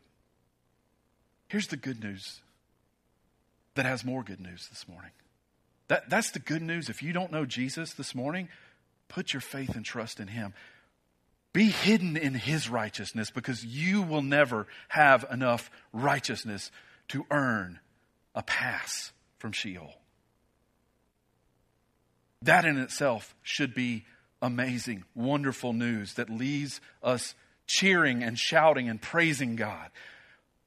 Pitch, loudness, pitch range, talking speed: 125 Hz, -29 LUFS, 105-145 Hz, 125 wpm